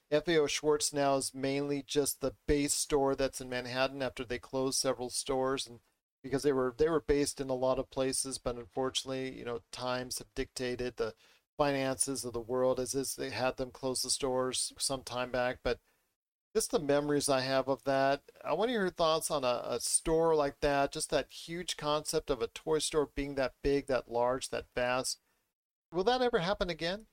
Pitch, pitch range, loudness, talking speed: 135 Hz, 125-150 Hz, -33 LUFS, 200 wpm